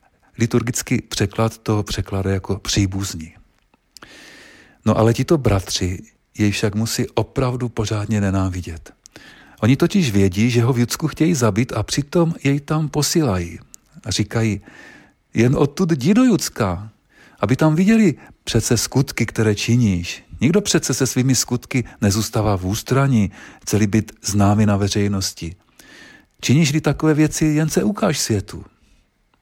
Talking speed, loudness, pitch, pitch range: 130 wpm, -19 LUFS, 115 Hz, 100-145 Hz